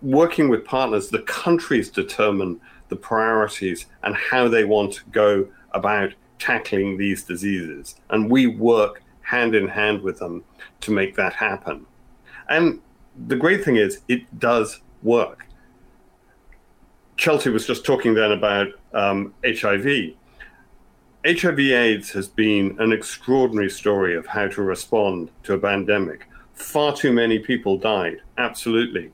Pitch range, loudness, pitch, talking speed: 100-120 Hz, -21 LUFS, 105 Hz, 135 wpm